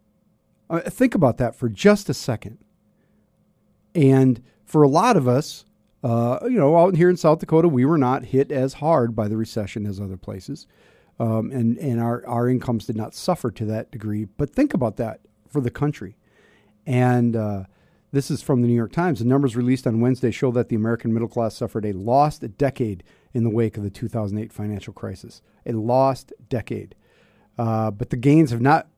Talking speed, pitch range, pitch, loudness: 195 wpm, 110-140 Hz, 120 Hz, -21 LUFS